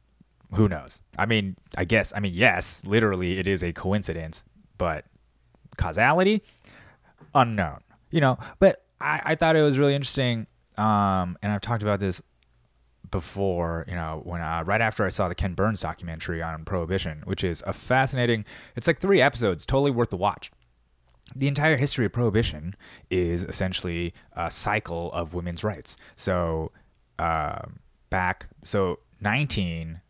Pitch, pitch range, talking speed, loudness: 100 Hz, 85-115 Hz, 155 wpm, -25 LUFS